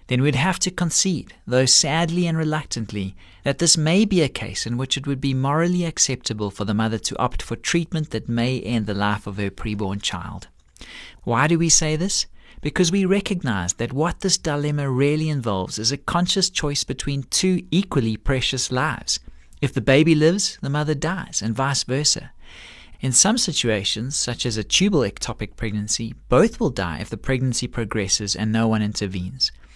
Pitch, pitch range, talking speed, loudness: 130 Hz, 110-160 Hz, 185 wpm, -21 LUFS